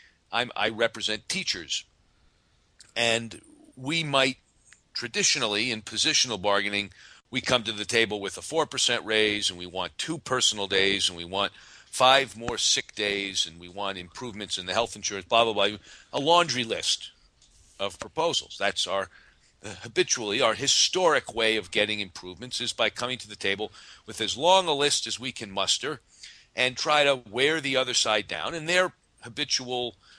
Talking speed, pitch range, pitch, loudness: 170 wpm, 100-125 Hz, 110 Hz, -25 LUFS